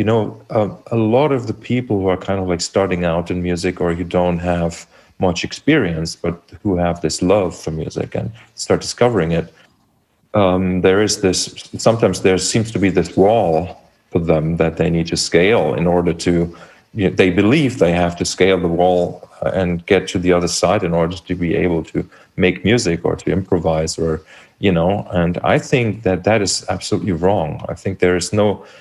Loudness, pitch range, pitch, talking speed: -17 LUFS, 85-95 Hz, 90 Hz, 205 wpm